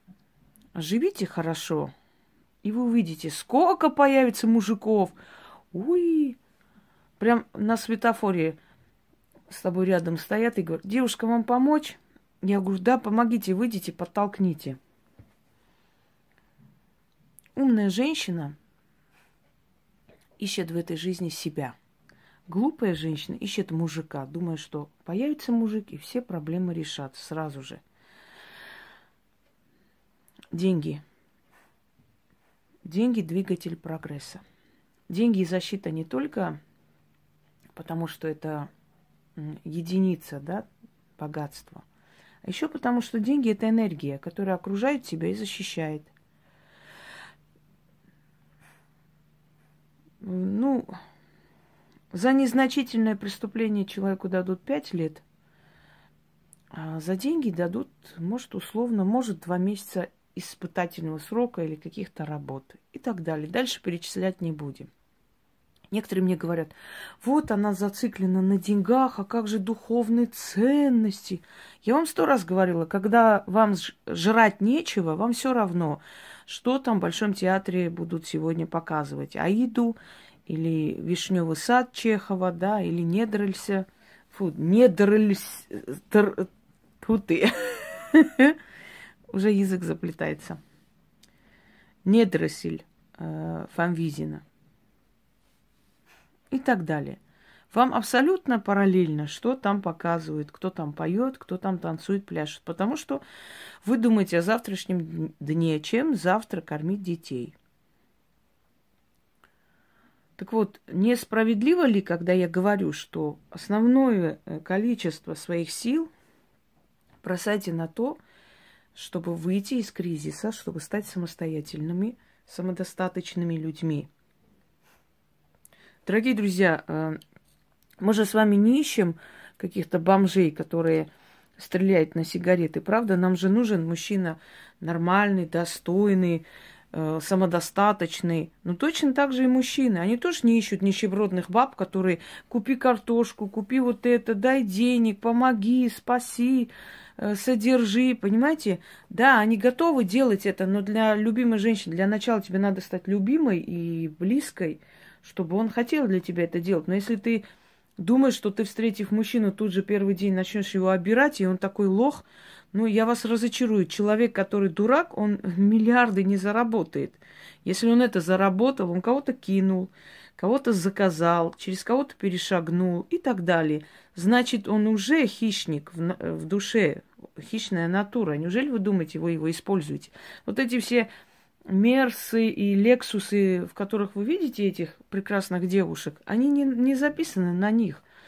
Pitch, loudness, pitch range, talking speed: 195 Hz, -25 LUFS, 170-230 Hz, 110 wpm